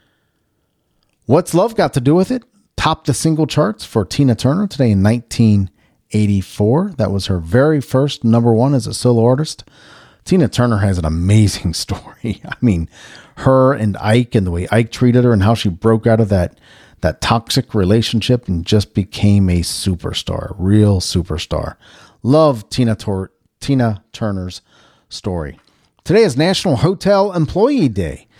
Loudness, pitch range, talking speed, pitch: -15 LUFS, 100-140 Hz, 155 wpm, 115 Hz